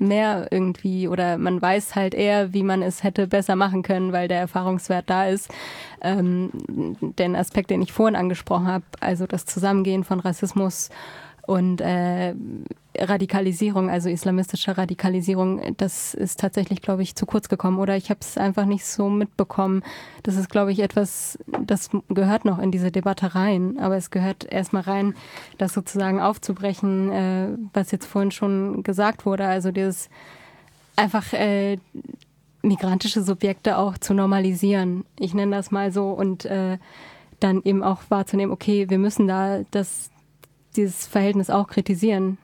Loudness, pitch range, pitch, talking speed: -23 LUFS, 185-200 Hz, 195 Hz, 150 wpm